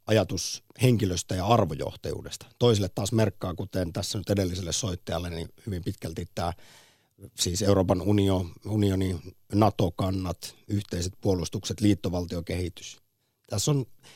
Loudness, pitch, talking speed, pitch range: -28 LUFS, 100 Hz, 110 wpm, 90-110 Hz